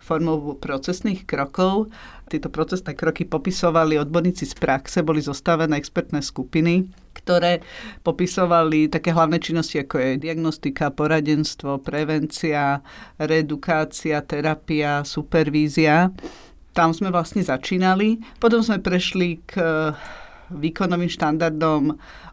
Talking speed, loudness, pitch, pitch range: 100 wpm, -21 LUFS, 160 Hz, 150-175 Hz